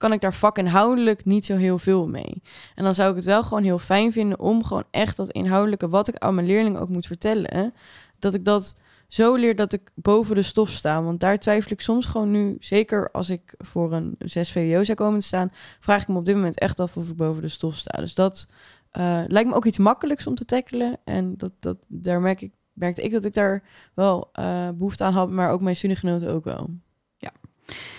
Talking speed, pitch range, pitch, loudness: 240 wpm, 180-210 Hz, 195 Hz, -22 LUFS